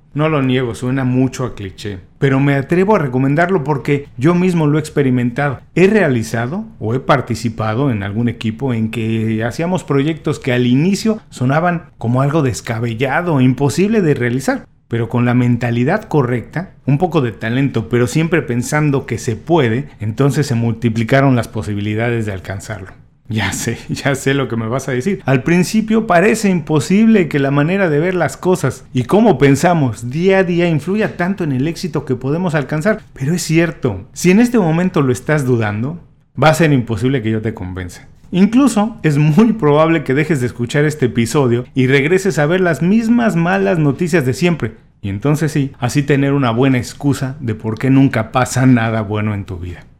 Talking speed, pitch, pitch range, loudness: 185 wpm, 140 Hz, 120-165 Hz, -15 LUFS